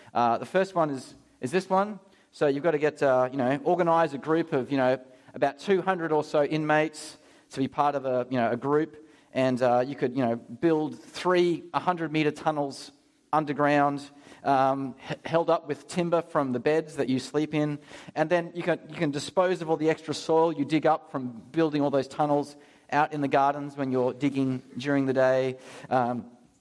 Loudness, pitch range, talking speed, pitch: -27 LUFS, 135-160 Hz, 215 wpm, 145 Hz